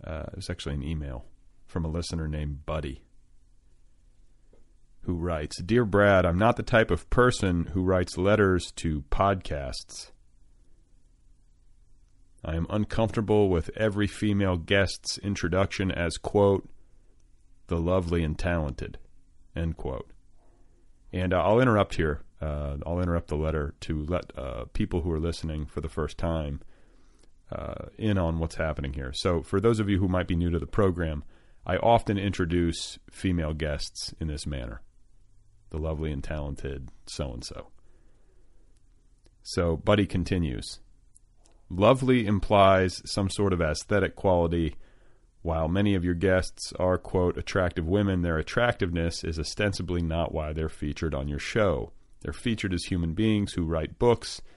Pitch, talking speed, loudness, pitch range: 85 Hz, 145 wpm, -27 LUFS, 80-100 Hz